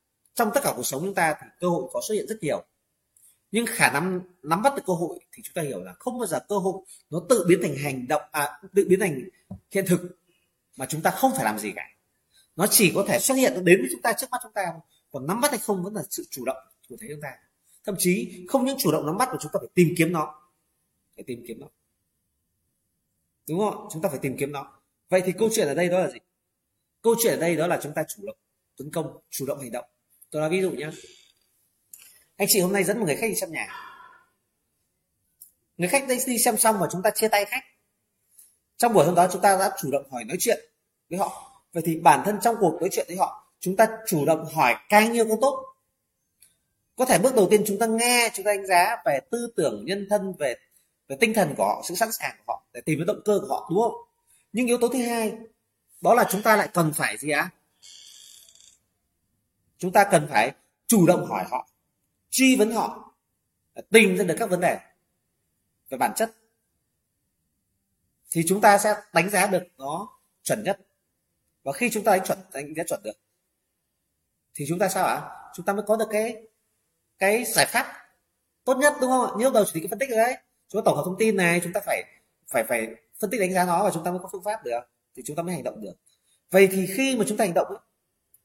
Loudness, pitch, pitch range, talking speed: -24 LUFS, 195 Hz, 165-225 Hz, 240 wpm